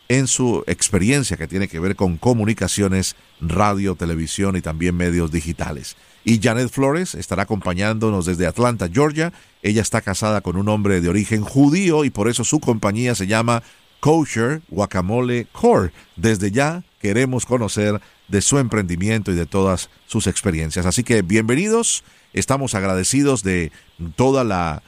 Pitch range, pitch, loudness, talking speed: 95-125 Hz, 105 Hz, -19 LUFS, 150 wpm